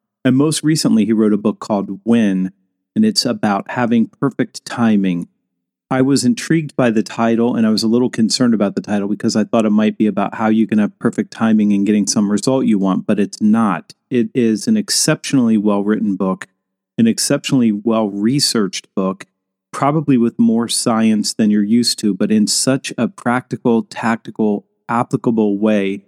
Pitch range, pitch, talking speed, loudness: 105-125 Hz, 110 Hz, 180 wpm, -16 LUFS